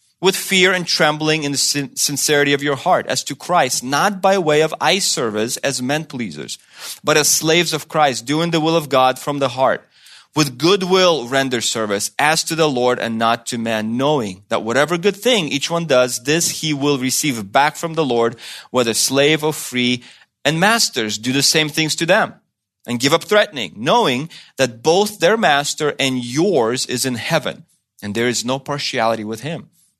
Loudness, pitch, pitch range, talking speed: -17 LUFS, 145 Hz, 125-160 Hz, 195 wpm